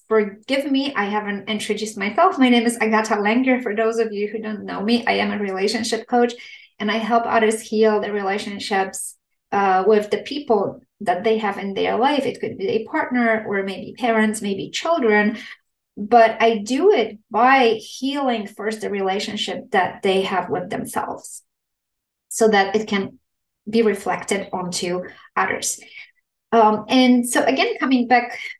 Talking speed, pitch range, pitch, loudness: 165 wpm, 205-240 Hz, 220 Hz, -20 LUFS